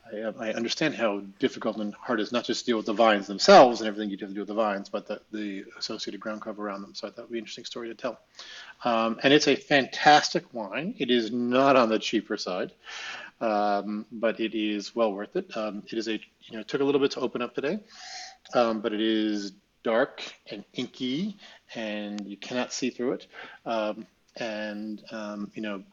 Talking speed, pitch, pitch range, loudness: 215 wpm, 110 Hz, 105-125 Hz, -27 LUFS